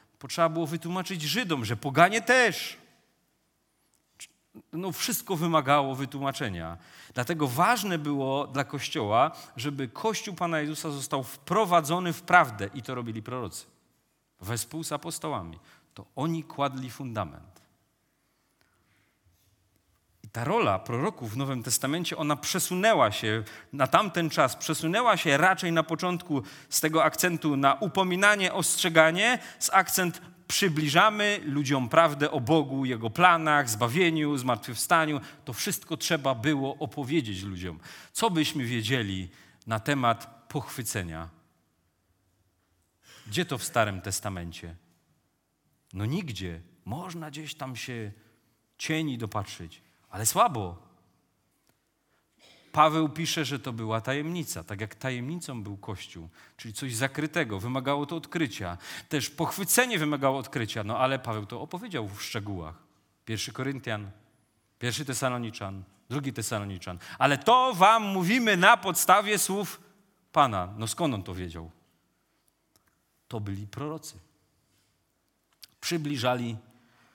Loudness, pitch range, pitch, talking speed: -27 LUFS, 110-165 Hz, 135 Hz, 115 wpm